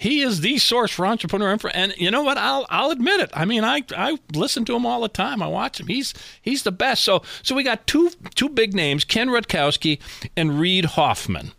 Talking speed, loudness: 235 wpm, -20 LUFS